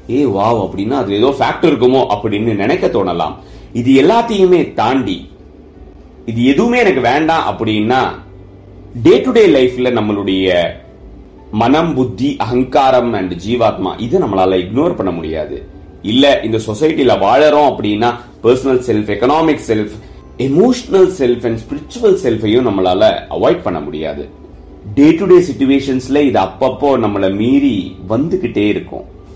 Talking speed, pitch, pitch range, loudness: 110 wpm, 120 Hz, 100-145 Hz, -13 LUFS